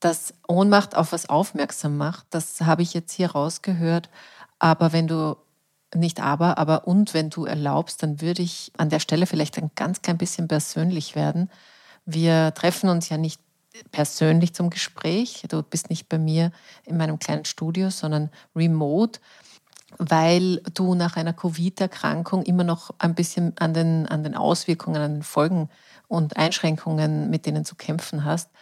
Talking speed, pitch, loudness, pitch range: 165 wpm, 165 Hz, -23 LUFS, 155-175 Hz